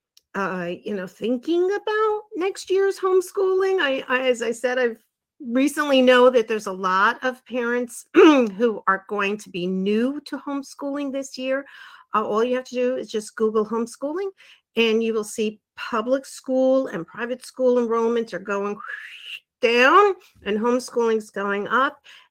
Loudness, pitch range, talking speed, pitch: -22 LUFS, 220-285 Hz, 160 wpm, 250 Hz